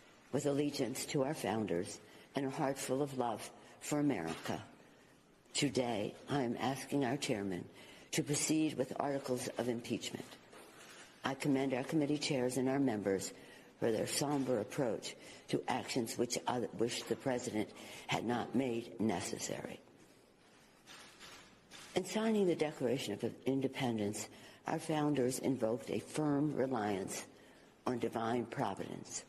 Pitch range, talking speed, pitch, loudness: 115-145 Hz, 130 wpm, 130 Hz, -37 LUFS